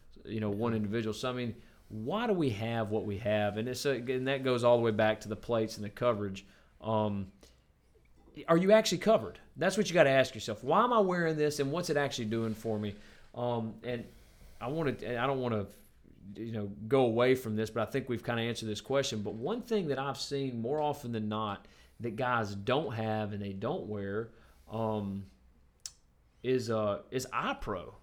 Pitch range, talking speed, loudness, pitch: 105-130 Hz, 215 wpm, -32 LUFS, 115 Hz